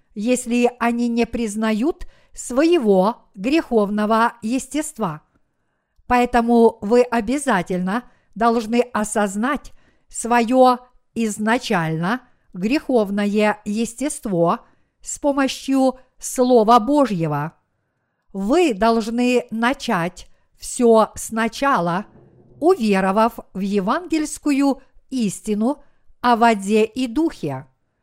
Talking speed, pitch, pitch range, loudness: 70 wpm, 235 Hz, 210-255 Hz, -19 LUFS